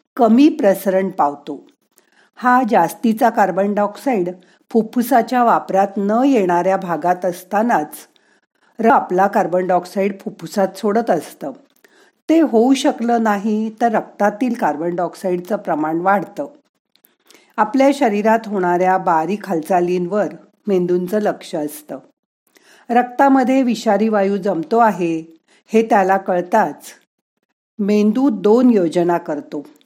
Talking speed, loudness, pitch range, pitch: 100 wpm, -17 LUFS, 180-235 Hz, 205 Hz